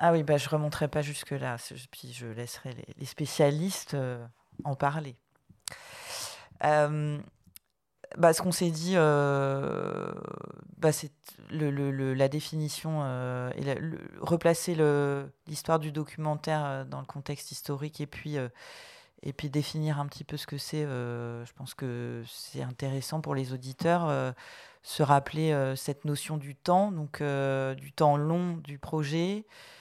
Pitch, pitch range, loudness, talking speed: 150 Hz, 135-155 Hz, -30 LUFS, 160 wpm